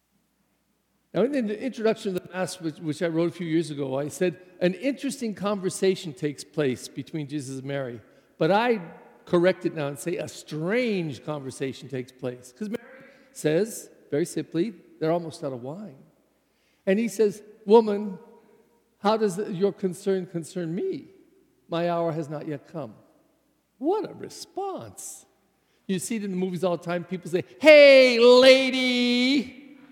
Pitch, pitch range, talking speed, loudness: 185 Hz, 160-235 Hz, 160 wpm, -24 LUFS